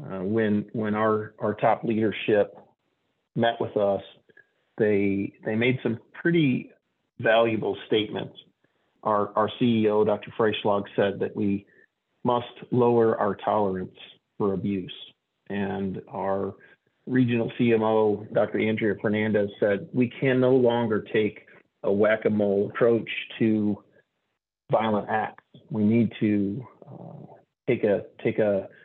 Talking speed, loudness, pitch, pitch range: 125 wpm, -25 LUFS, 110 Hz, 100-115 Hz